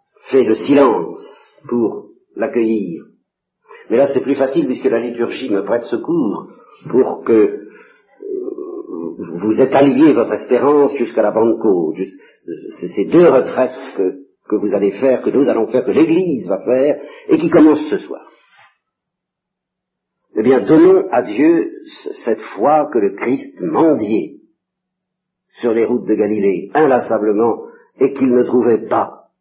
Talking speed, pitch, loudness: 145 wpm, 330 Hz, -15 LUFS